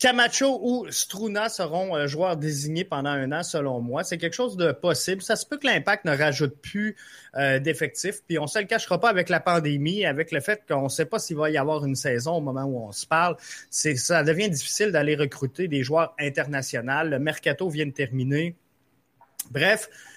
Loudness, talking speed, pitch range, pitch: -25 LUFS, 205 wpm, 145-185 Hz, 160 Hz